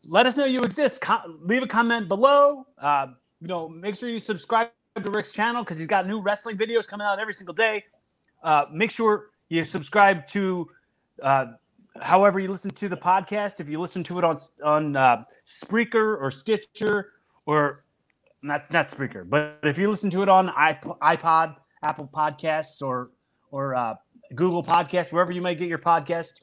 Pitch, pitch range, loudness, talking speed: 180 Hz, 160-215 Hz, -24 LUFS, 185 wpm